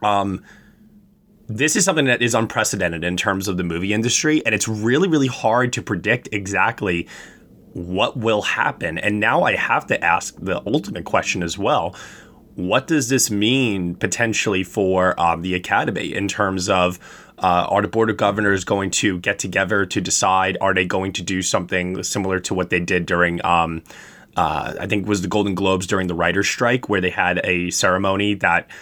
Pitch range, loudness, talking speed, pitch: 90-110 Hz, -19 LUFS, 185 wpm, 100 Hz